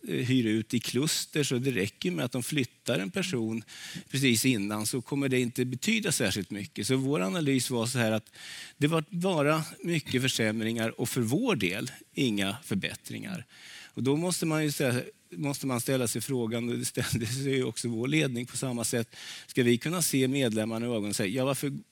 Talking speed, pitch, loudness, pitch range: 195 wpm, 130 Hz, -29 LUFS, 115-140 Hz